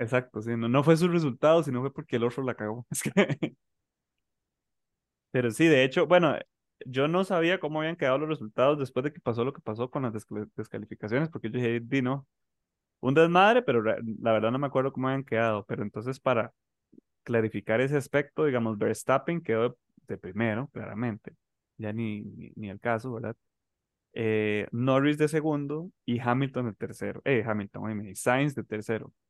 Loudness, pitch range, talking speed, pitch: -28 LUFS, 110-145 Hz, 185 wpm, 125 Hz